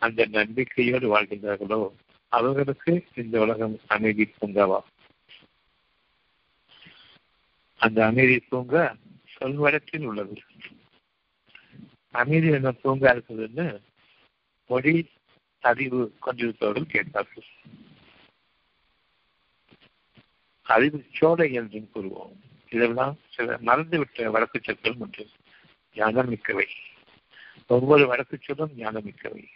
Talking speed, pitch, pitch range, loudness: 75 wpm, 120 Hz, 110-140 Hz, -24 LUFS